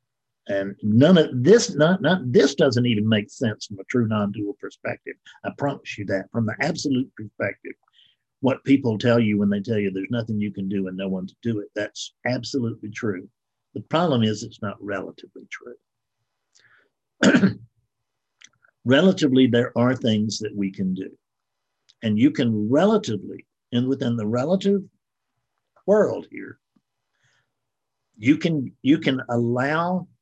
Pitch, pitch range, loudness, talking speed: 115 Hz, 105-135 Hz, -22 LUFS, 150 wpm